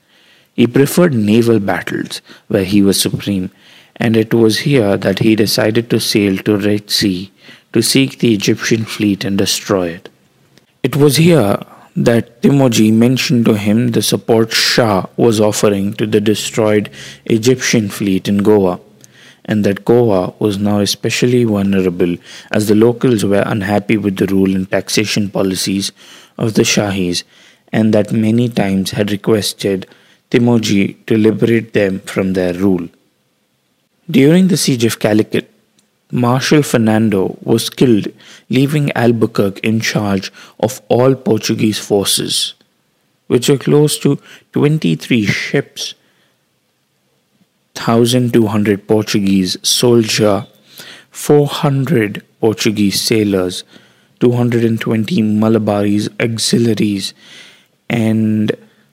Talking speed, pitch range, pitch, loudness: 115 wpm, 100-120 Hz, 110 Hz, -13 LUFS